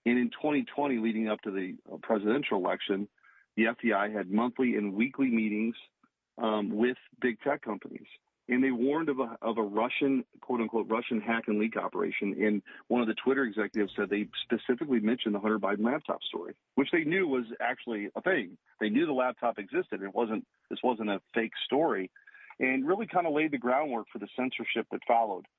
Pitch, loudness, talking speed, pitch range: 115 Hz, -31 LUFS, 190 wpm, 110-130 Hz